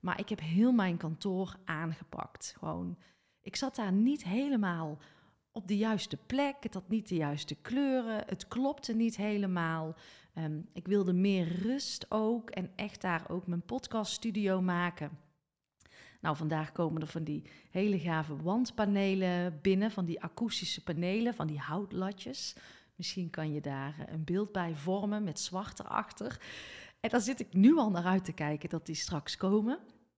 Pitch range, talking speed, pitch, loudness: 165-215 Hz, 165 wpm, 185 Hz, -34 LUFS